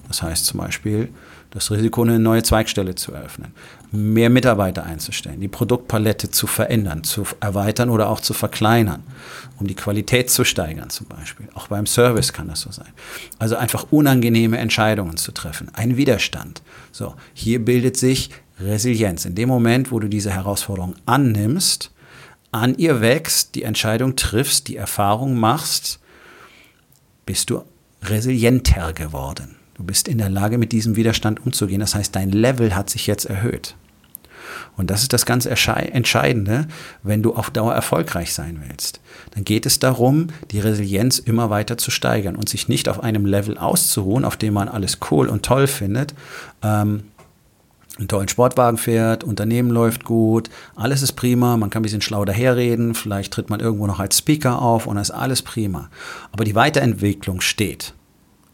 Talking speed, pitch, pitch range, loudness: 165 wpm, 110 Hz, 100-120 Hz, -19 LUFS